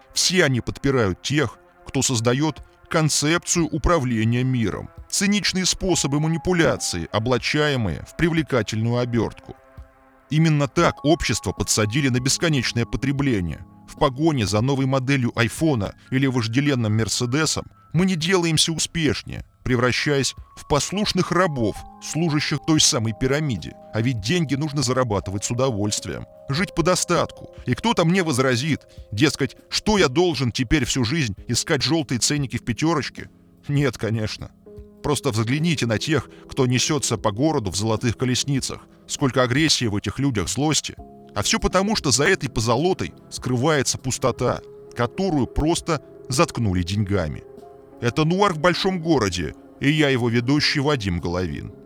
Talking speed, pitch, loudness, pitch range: 130 wpm, 130 Hz, -21 LUFS, 110-155 Hz